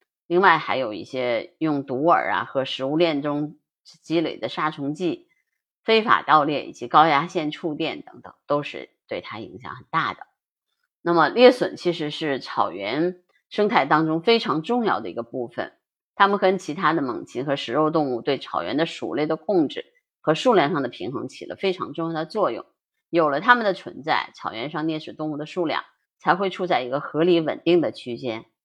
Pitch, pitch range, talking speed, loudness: 160 Hz, 150-190 Hz, 280 characters per minute, -23 LUFS